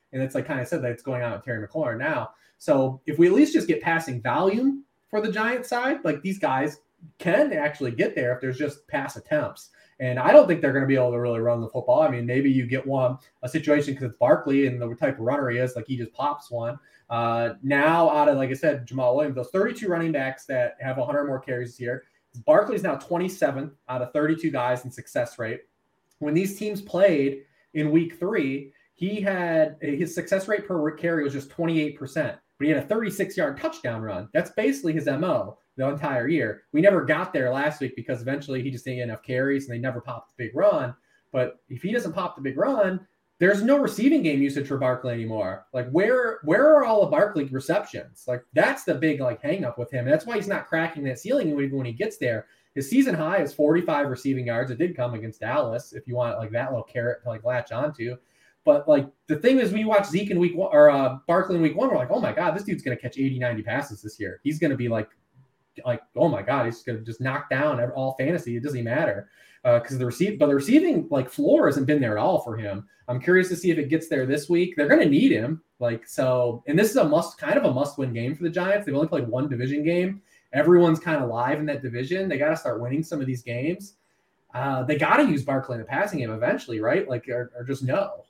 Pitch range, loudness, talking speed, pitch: 125-175 Hz, -24 LUFS, 245 wpm, 145 Hz